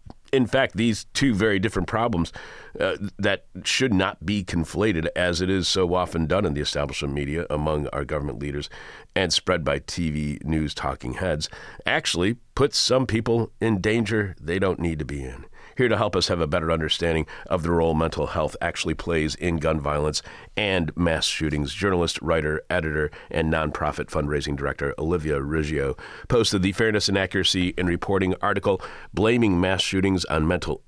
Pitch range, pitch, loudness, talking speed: 75-100 Hz, 85 Hz, -24 LUFS, 175 wpm